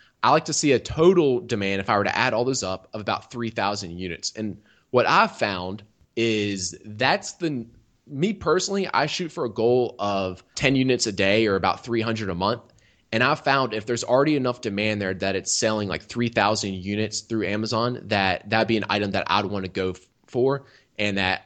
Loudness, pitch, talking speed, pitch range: -23 LUFS, 110 Hz, 205 wpm, 100-125 Hz